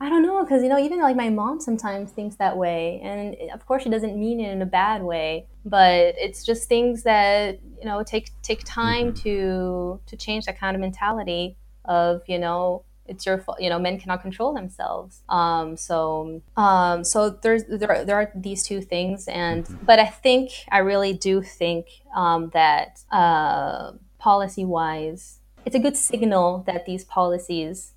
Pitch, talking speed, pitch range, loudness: 195 Hz, 185 wpm, 175-220 Hz, -22 LUFS